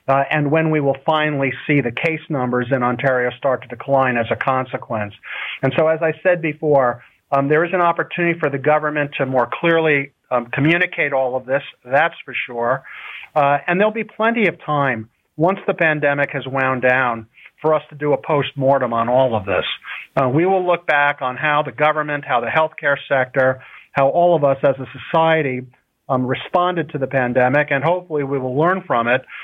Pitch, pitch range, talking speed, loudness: 140 Hz, 130-160 Hz, 200 wpm, -18 LUFS